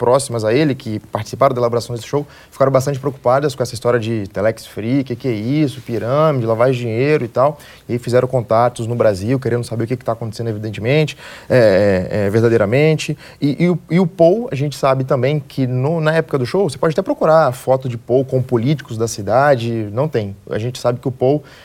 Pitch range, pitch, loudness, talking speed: 115-145 Hz, 130 Hz, -17 LUFS, 215 wpm